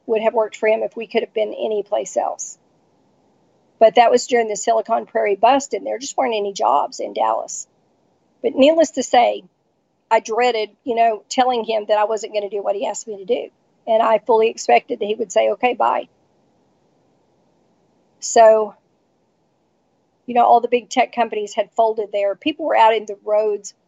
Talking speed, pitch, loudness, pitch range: 195 wpm, 225 Hz, -18 LUFS, 215-240 Hz